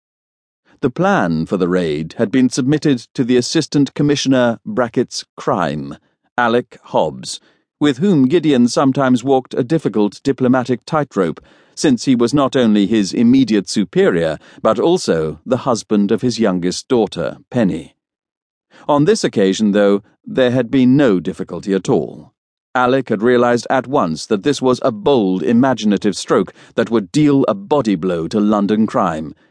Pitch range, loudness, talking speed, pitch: 105-140 Hz, -16 LUFS, 150 wpm, 125 Hz